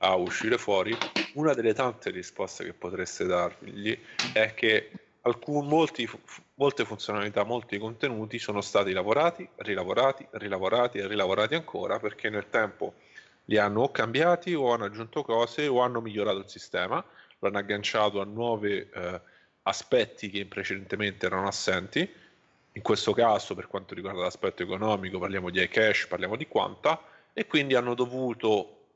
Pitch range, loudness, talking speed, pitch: 100-125 Hz, -28 LUFS, 150 wpm, 110 Hz